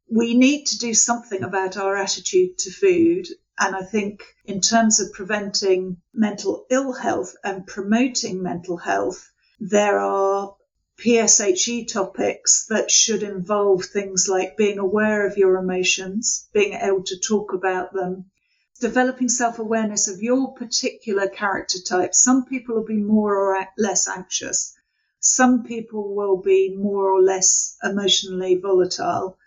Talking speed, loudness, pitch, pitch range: 140 wpm, -20 LUFS, 200 Hz, 190-230 Hz